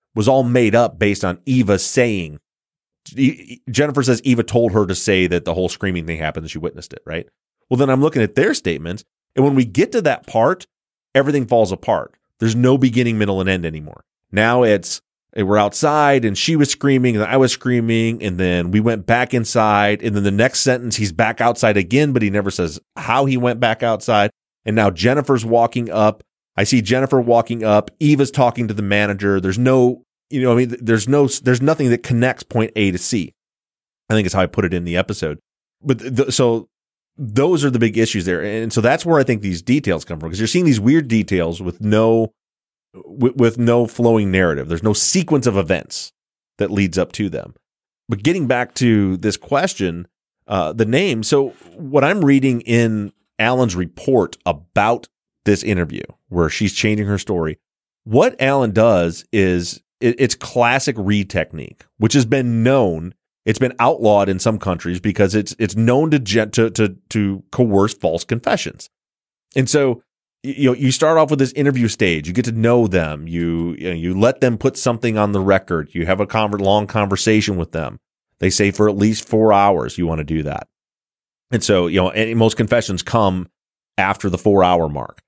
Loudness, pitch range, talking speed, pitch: -17 LUFS, 95-125 Hz, 200 wpm, 110 Hz